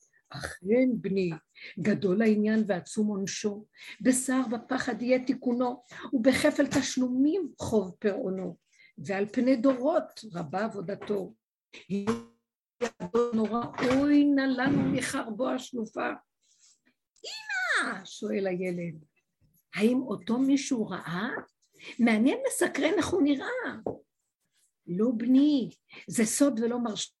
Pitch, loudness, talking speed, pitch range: 235 Hz, -28 LUFS, 95 wpm, 200-270 Hz